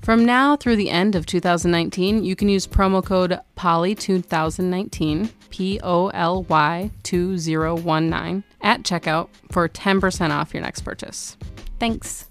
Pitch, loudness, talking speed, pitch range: 180 Hz, -21 LUFS, 110 wpm, 165-195 Hz